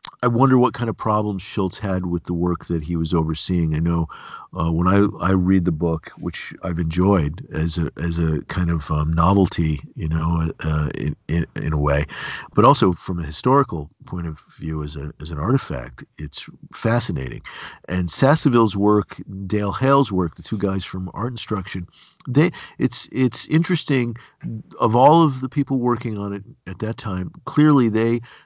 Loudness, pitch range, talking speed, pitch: -21 LUFS, 80-115 Hz, 185 wpm, 95 Hz